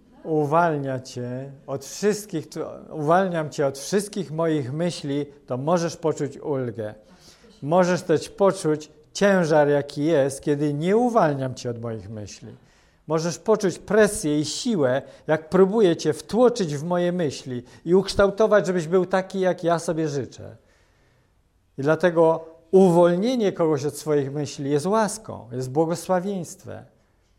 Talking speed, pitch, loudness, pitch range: 130 wpm, 155 Hz, -23 LUFS, 140-185 Hz